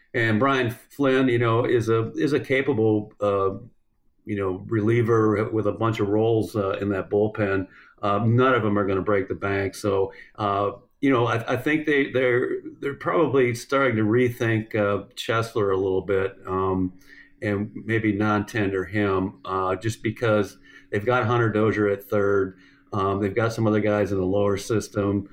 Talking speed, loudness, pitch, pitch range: 180 wpm, -23 LUFS, 105 Hz, 100-120 Hz